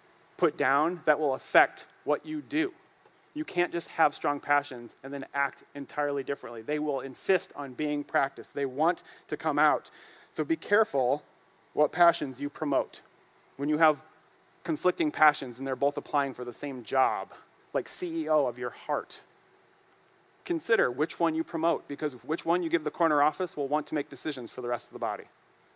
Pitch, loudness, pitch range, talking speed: 150 Hz, -29 LUFS, 140-170 Hz, 185 wpm